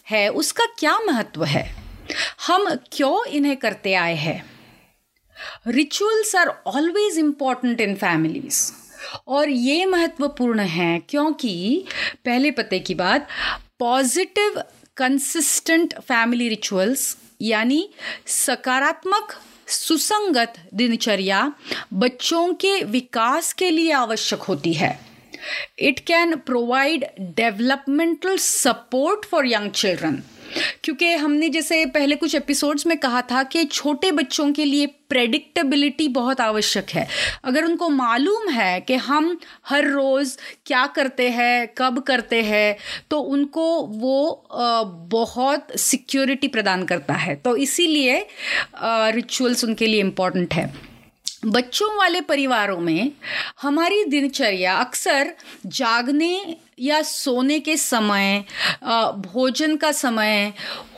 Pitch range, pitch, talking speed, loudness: 230-315 Hz, 270 Hz, 110 wpm, -20 LUFS